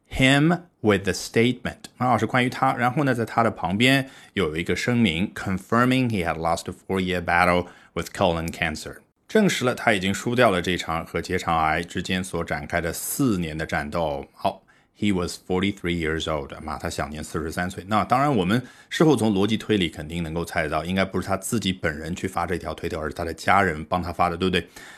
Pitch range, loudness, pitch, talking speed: 85-115 Hz, -24 LUFS, 90 Hz, 465 characters per minute